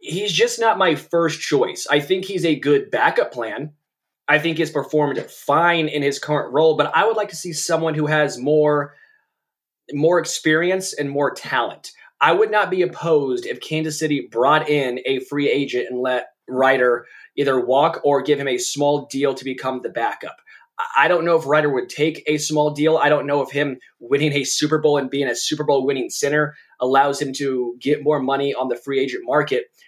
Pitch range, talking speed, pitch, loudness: 140-165 Hz, 205 wpm, 150 Hz, -19 LUFS